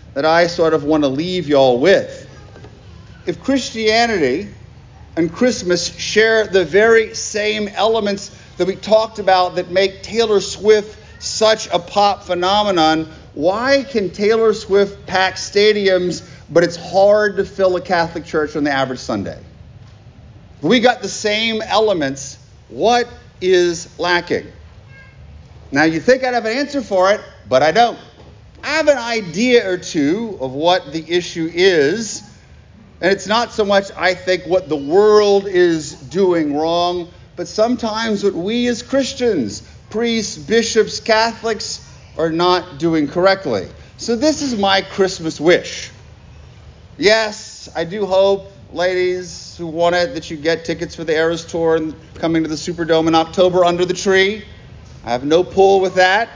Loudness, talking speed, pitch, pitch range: -16 LUFS, 155 wpm, 185 Hz, 165-215 Hz